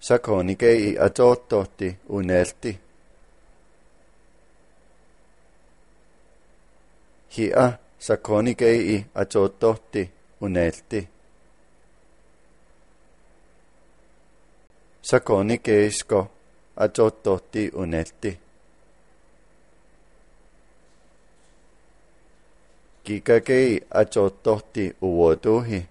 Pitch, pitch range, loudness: 100 Hz, 90-115 Hz, -22 LUFS